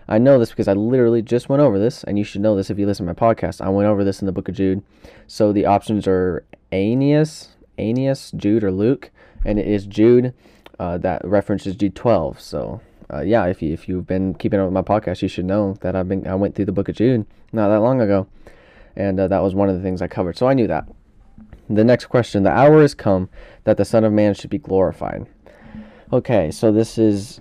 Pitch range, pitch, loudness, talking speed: 95-110 Hz, 100 Hz, -18 LUFS, 245 wpm